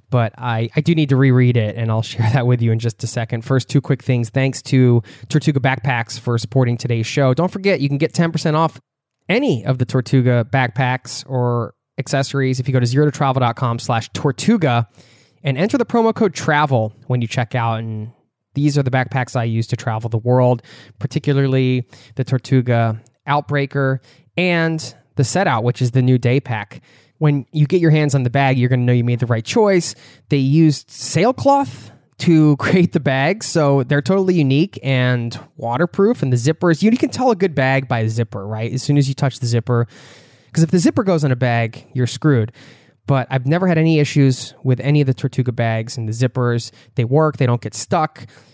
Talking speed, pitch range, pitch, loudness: 205 wpm, 120-150 Hz, 130 Hz, -17 LUFS